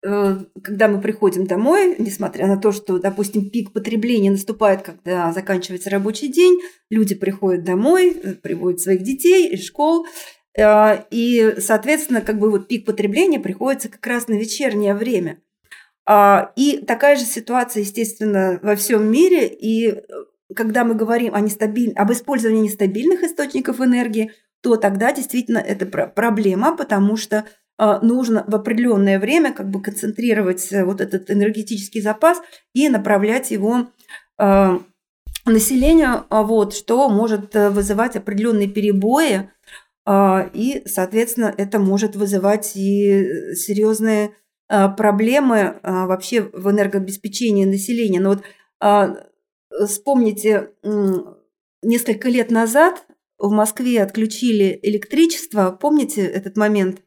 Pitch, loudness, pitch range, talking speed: 215 Hz, -17 LUFS, 200-240 Hz, 120 wpm